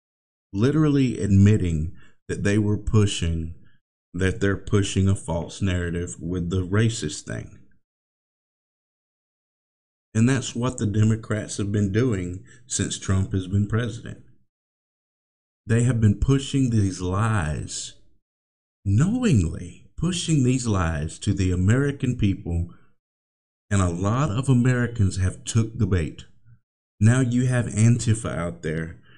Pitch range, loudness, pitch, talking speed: 90-115 Hz, -23 LUFS, 100 Hz, 120 wpm